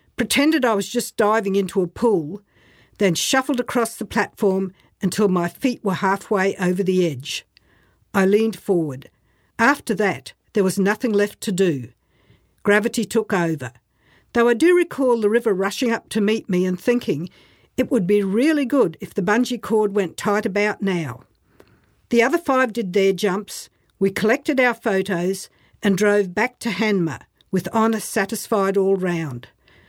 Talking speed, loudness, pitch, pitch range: 165 wpm, -20 LUFS, 205 Hz, 185-230 Hz